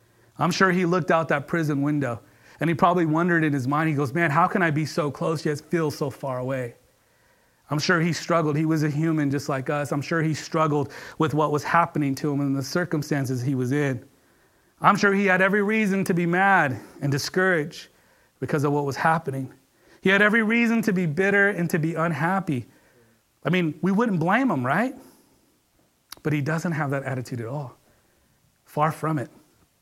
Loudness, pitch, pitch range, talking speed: -23 LUFS, 155 Hz, 145-175 Hz, 205 wpm